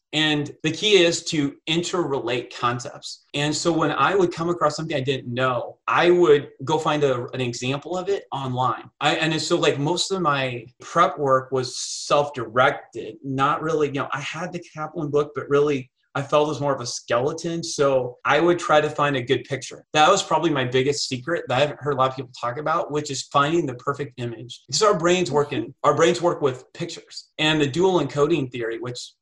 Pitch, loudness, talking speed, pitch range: 145 Hz, -22 LUFS, 215 wpm, 130-165 Hz